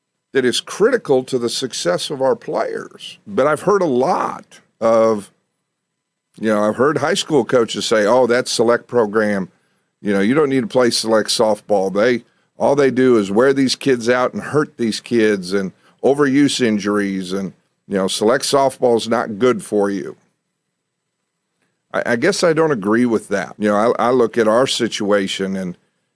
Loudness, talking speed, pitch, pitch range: -17 LUFS, 180 wpm, 110 Hz, 100-130 Hz